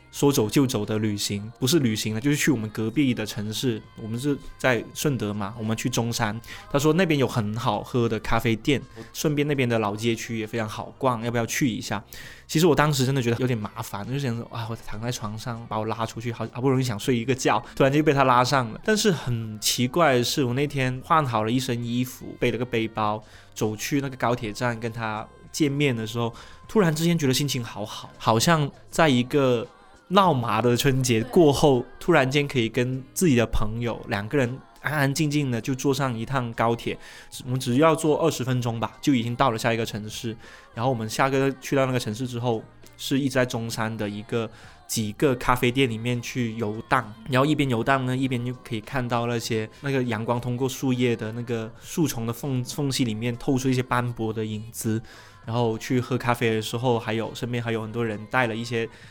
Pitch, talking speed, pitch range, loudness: 120 Hz, 320 characters per minute, 115-135 Hz, -25 LUFS